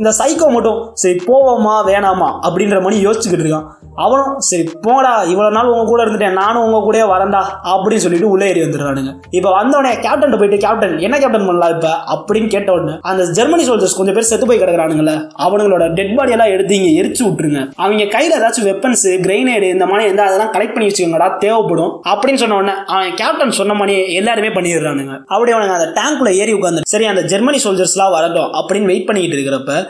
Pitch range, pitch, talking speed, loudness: 180-225 Hz, 200 Hz, 180 wpm, -13 LUFS